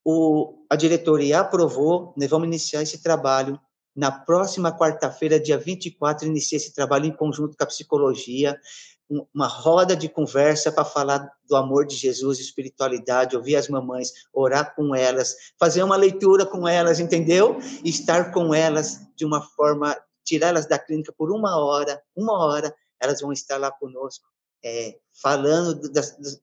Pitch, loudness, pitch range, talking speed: 150 Hz, -22 LUFS, 140-165 Hz, 165 wpm